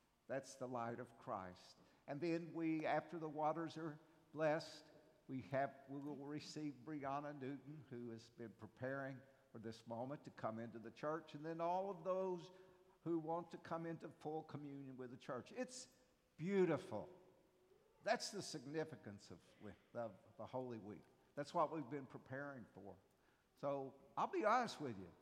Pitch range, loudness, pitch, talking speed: 125-165 Hz, -47 LUFS, 145 Hz, 165 wpm